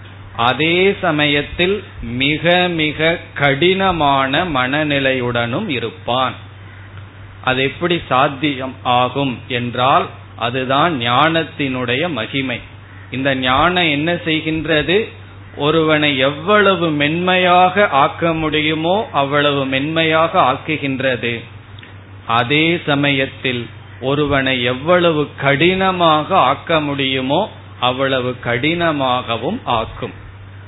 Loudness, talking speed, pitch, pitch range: -16 LUFS, 70 wpm, 135 Hz, 120-160 Hz